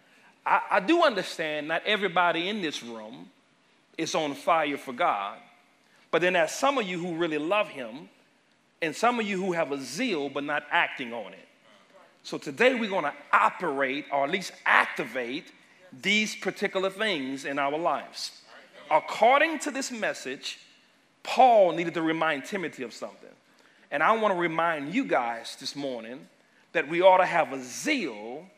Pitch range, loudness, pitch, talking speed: 145-215 Hz, -26 LUFS, 175 Hz, 170 wpm